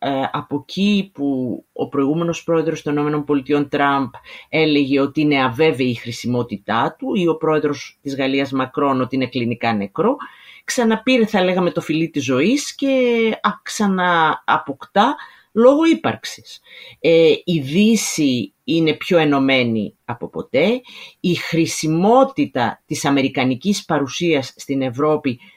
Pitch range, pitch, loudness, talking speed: 135-195 Hz, 155 Hz, -18 LUFS, 120 wpm